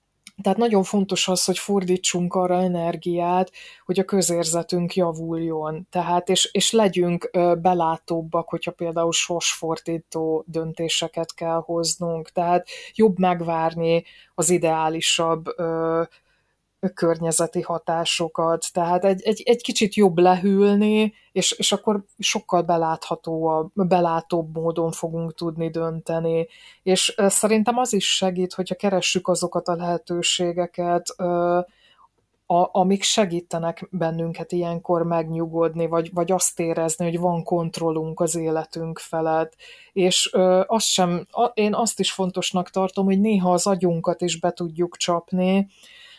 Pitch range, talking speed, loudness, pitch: 165-185 Hz, 120 wpm, -22 LUFS, 175 Hz